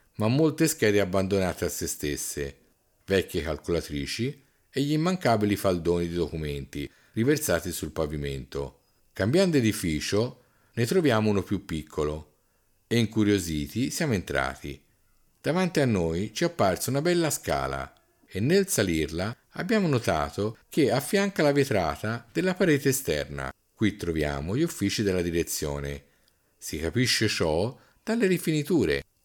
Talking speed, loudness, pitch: 125 wpm, -27 LUFS, 105 Hz